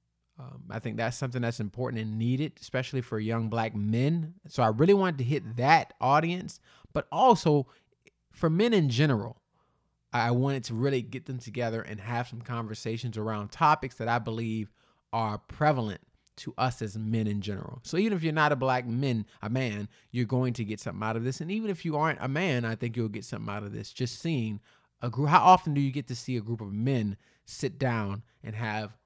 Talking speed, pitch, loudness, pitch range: 215 wpm, 120 Hz, -29 LUFS, 110-145 Hz